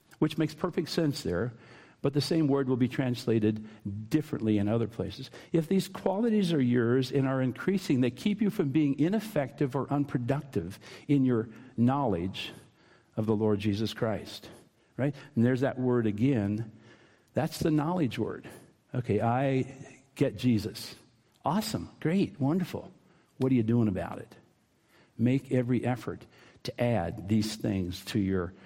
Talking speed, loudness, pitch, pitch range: 150 wpm, -30 LUFS, 125 Hz, 110-145 Hz